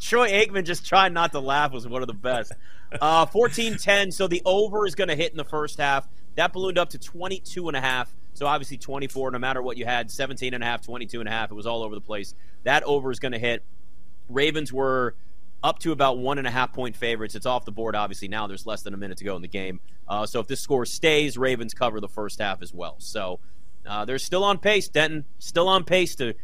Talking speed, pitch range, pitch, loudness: 255 wpm, 110-160 Hz, 130 Hz, -25 LUFS